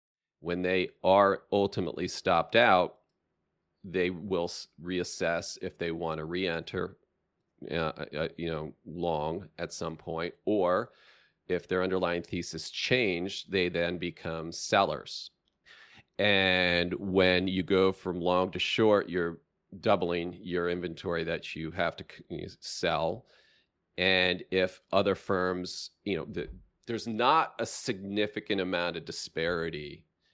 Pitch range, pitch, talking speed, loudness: 85-95 Hz, 90 Hz, 125 wpm, -30 LUFS